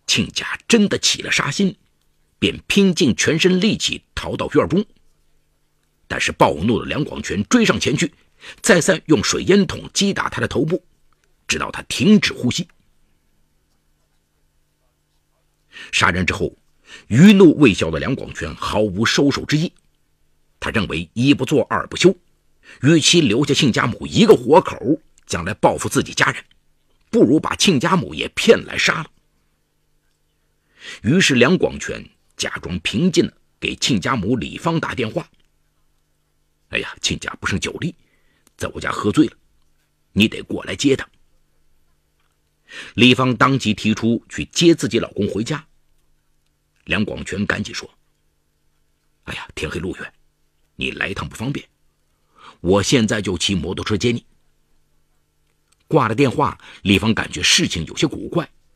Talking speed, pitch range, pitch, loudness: 205 characters per minute, 75-125 Hz, 75 Hz, -18 LUFS